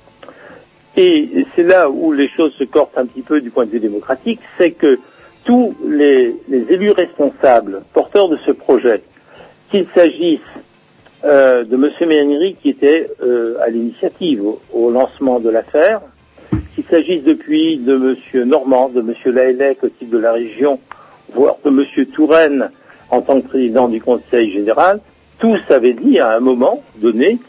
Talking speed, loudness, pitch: 165 wpm, -14 LUFS, 140 Hz